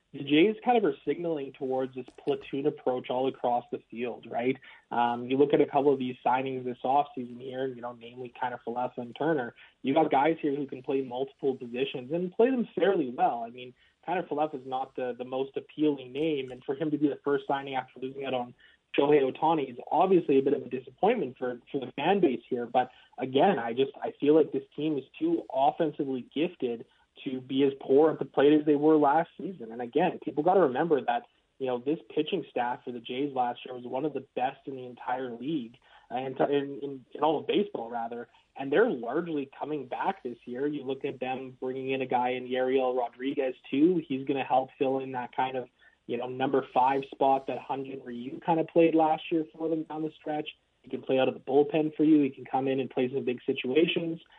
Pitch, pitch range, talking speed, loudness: 135 Hz, 125-150 Hz, 230 wpm, -29 LUFS